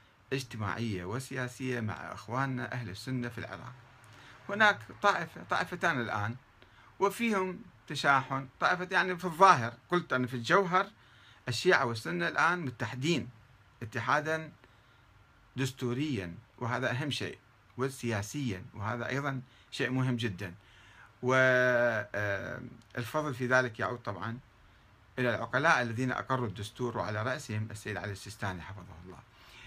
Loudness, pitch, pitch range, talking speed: -32 LUFS, 125 Hz, 110-135 Hz, 110 wpm